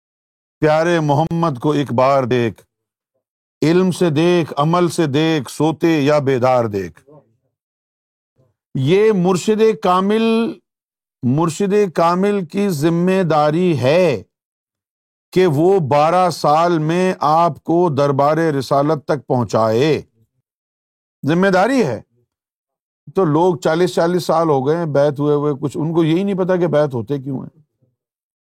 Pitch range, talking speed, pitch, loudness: 135-175 Hz, 130 wpm, 155 Hz, -16 LUFS